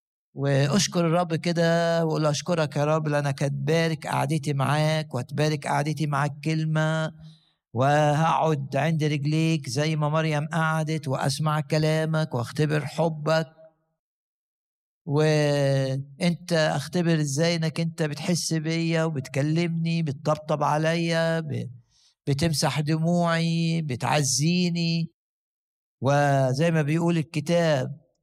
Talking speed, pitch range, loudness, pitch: 90 wpm, 145-165 Hz, -24 LUFS, 155 Hz